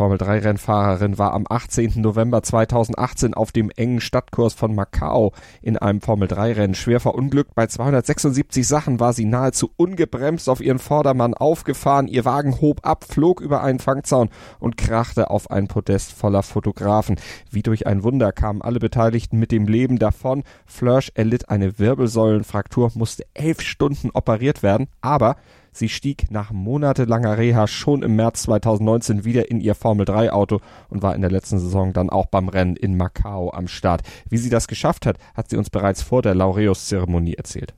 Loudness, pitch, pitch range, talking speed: -20 LUFS, 115 Hz, 100-125 Hz, 175 wpm